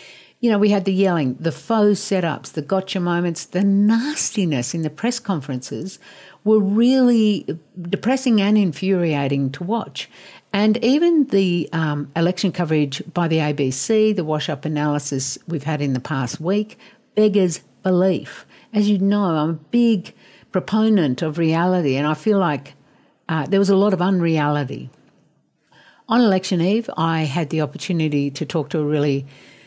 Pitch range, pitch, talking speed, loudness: 155-205 Hz, 180 Hz, 160 wpm, -20 LUFS